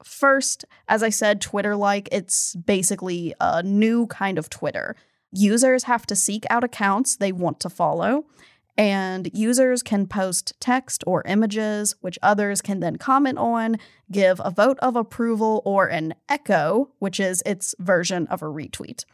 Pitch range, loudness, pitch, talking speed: 185-230 Hz, -22 LUFS, 205 Hz, 160 wpm